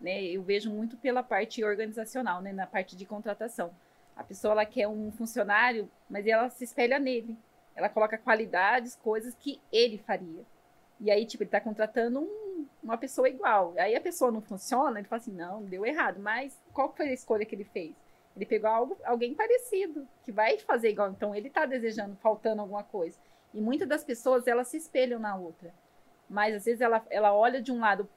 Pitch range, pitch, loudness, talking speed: 205-255 Hz, 225 Hz, -30 LUFS, 200 wpm